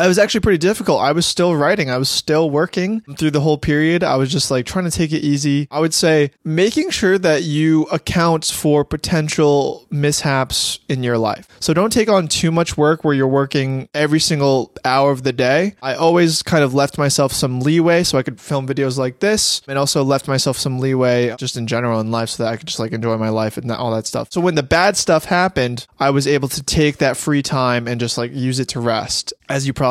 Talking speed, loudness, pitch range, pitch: 240 wpm, -17 LUFS, 130-165 Hz, 145 Hz